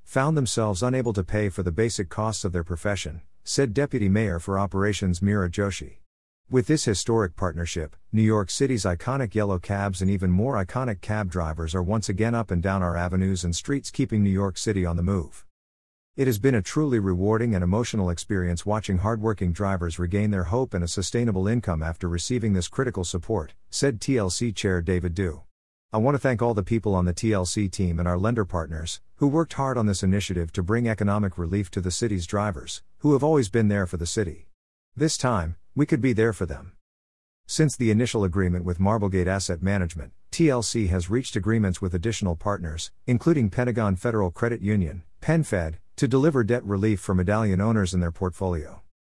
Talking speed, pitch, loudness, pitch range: 190 wpm, 100 Hz, -25 LUFS, 90-115 Hz